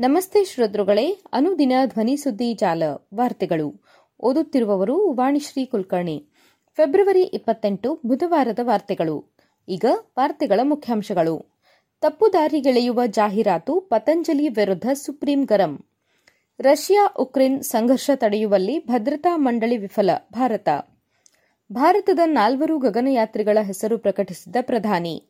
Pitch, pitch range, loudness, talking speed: 250 Hz, 210-300 Hz, -20 LUFS, 90 wpm